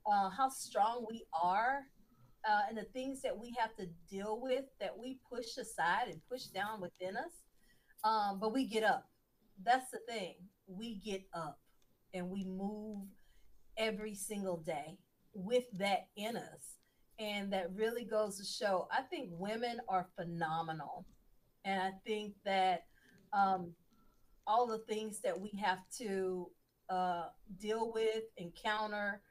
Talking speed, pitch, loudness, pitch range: 145 wpm, 210 Hz, -39 LUFS, 190-225 Hz